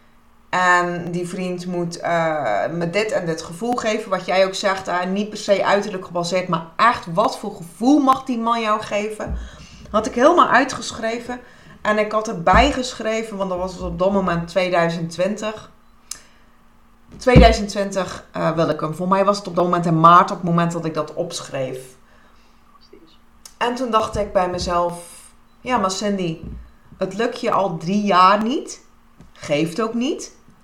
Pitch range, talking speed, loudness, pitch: 175-215 Hz, 170 wpm, -19 LUFS, 190 Hz